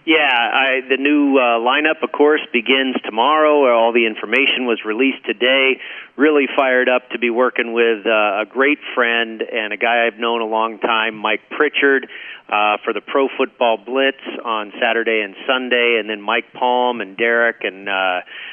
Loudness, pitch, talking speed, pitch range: -16 LUFS, 120 Hz, 180 wpm, 115-135 Hz